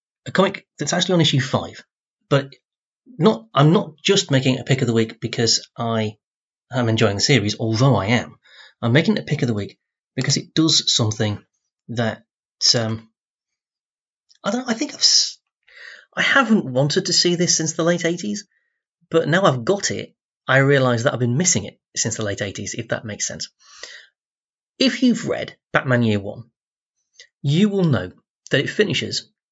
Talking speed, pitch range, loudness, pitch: 185 wpm, 115-175 Hz, -19 LUFS, 135 Hz